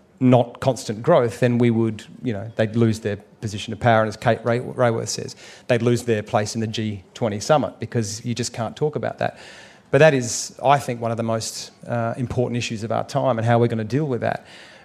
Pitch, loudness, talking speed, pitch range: 120 Hz, -22 LUFS, 235 wpm, 110-125 Hz